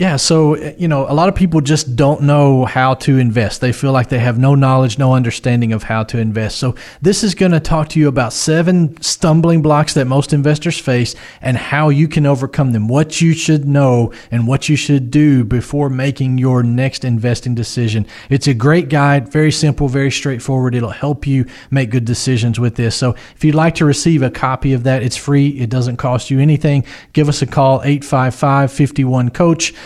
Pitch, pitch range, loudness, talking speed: 135 Hz, 125-150 Hz, -14 LUFS, 210 wpm